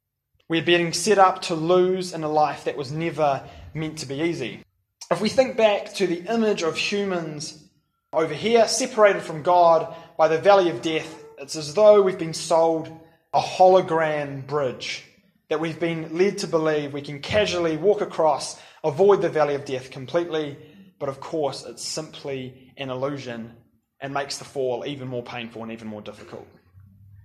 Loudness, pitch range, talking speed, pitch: -22 LUFS, 140-175 Hz, 175 wpm, 160 Hz